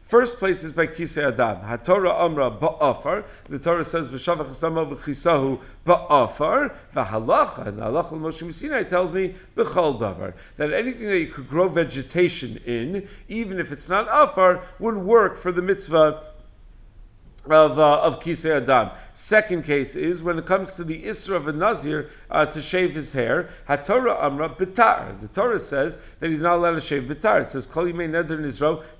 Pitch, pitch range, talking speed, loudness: 165 Hz, 145-180 Hz, 170 wpm, -22 LUFS